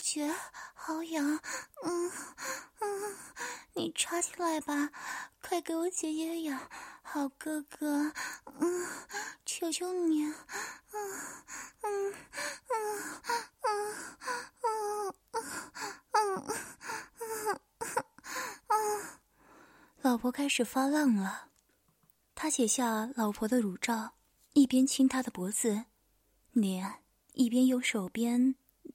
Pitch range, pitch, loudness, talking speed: 255-405 Hz, 315 Hz, -34 LUFS, 125 characters per minute